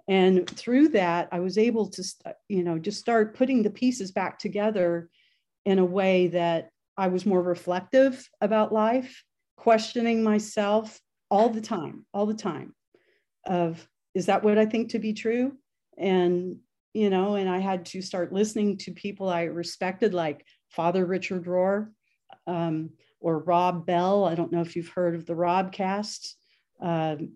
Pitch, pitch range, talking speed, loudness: 190 Hz, 175-215 Hz, 165 wpm, -26 LUFS